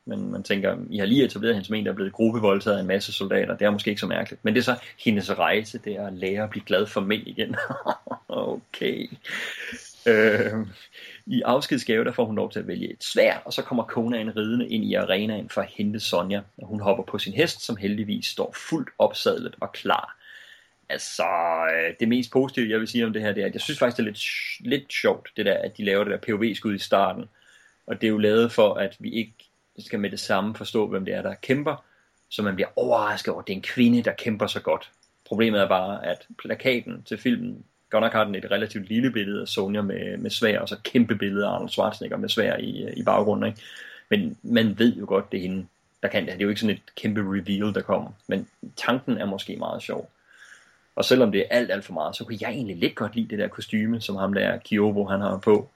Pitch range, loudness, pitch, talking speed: 100-115 Hz, -25 LUFS, 105 Hz, 245 wpm